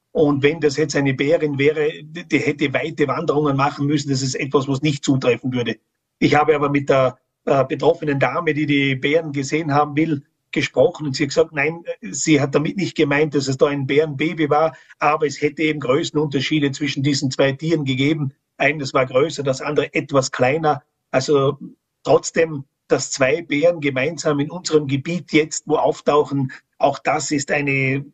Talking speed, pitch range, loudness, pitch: 180 wpm, 140-155 Hz, -19 LUFS, 150 Hz